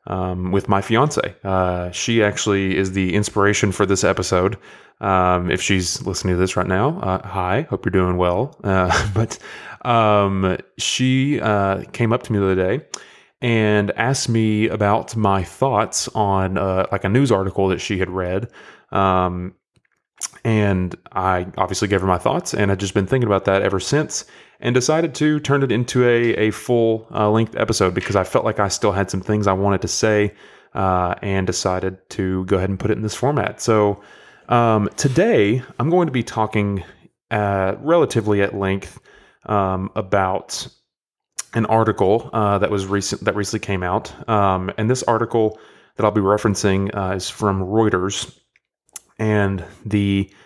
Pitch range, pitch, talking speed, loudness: 95-110 Hz, 100 Hz, 175 wpm, -19 LUFS